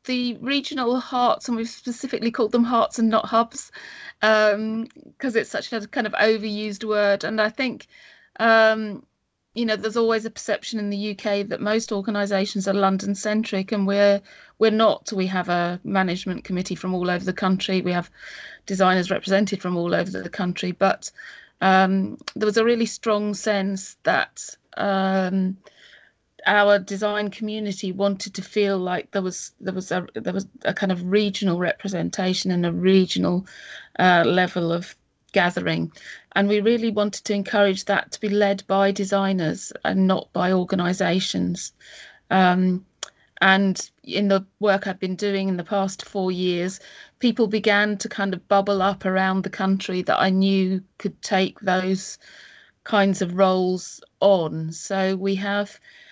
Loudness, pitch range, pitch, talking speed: -22 LUFS, 190-215 Hz, 200 Hz, 160 wpm